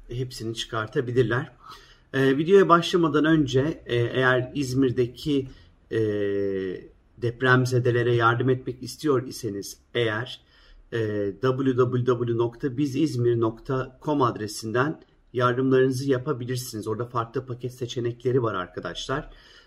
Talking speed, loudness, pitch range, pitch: 80 wpm, -25 LUFS, 115-130 Hz, 125 Hz